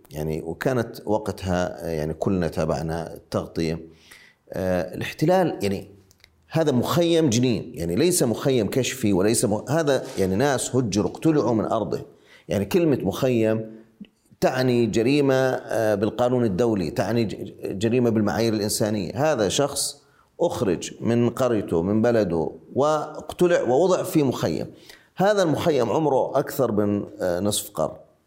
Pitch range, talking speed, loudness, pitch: 95-130 Hz, 120 wpm, -23 LUFS, 110 Hz